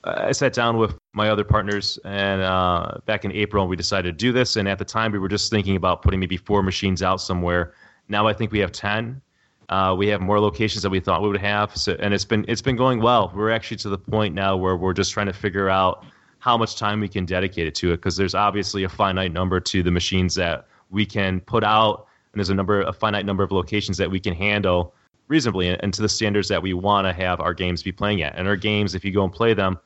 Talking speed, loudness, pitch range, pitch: 265 wpm, -22 LUFS, 95-105 Hz, 100 Hz